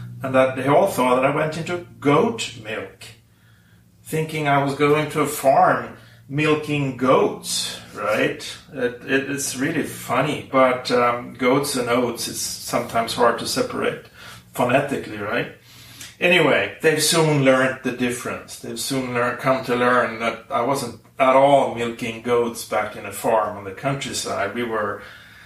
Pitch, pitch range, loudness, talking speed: 125 Hz, 115-140 Hz, -21 LUFS, 155 wpm